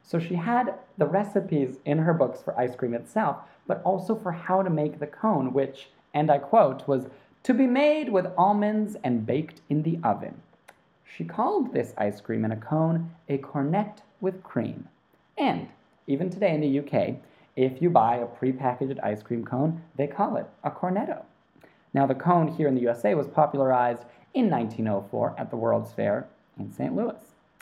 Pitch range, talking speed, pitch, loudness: 130-185 Hz, 185 wpm, 145 Hz, -26 LUFS